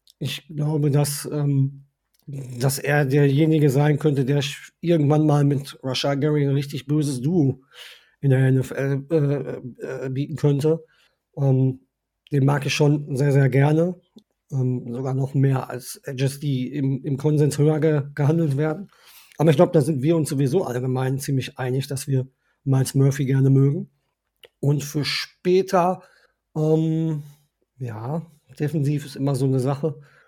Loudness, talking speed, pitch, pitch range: -22 LUFS, 150 wpm, 145 Hz, 135-150 Hz